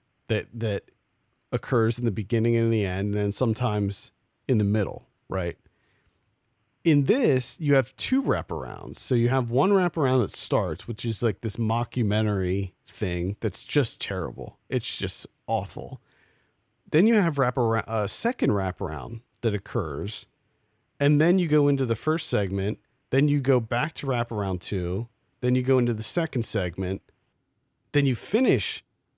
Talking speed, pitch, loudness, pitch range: 155 wpm, 115 Hz, -26 LUFS, 105-130 Hz